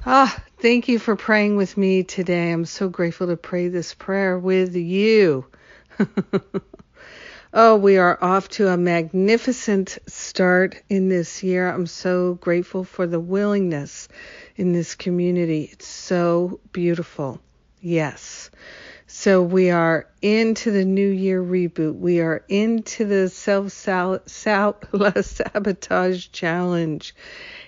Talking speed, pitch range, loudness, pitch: 125 wpm, 175-205 Hz, -20 LUFS, 185 Hz